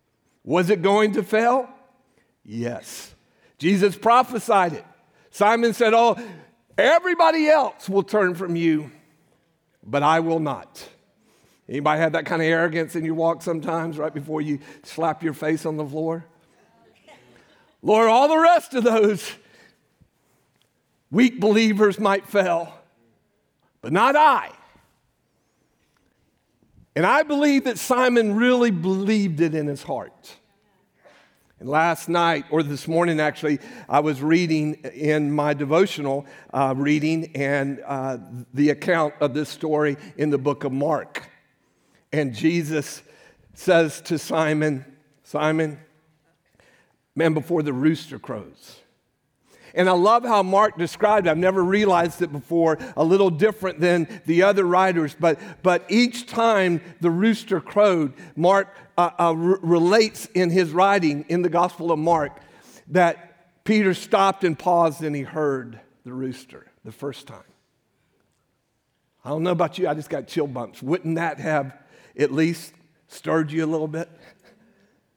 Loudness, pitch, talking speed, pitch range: -21 LUFS, 165 Hz, 140 wpm, 150-195 Hz